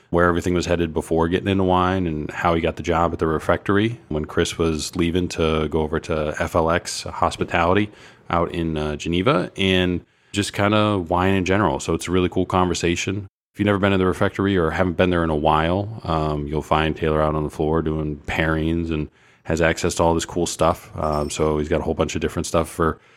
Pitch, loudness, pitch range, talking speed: 85 Hz, -21 LUFS, 80-90 Hz, 225 wpm